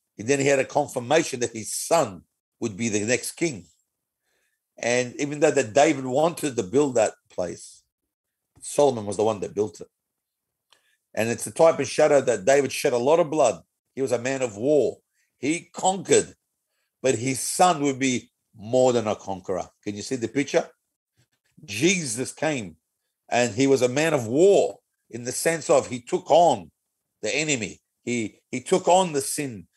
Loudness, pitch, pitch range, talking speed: -23 LUFS, 135 Hz, 120-150 Hz, 180 wpm